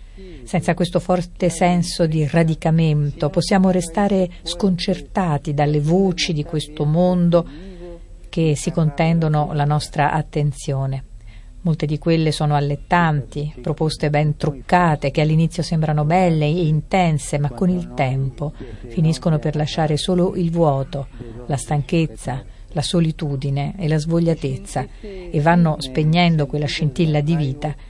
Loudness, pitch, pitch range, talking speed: -19 LUFS, 155 Hz, 145-175 Hz, 125 wpm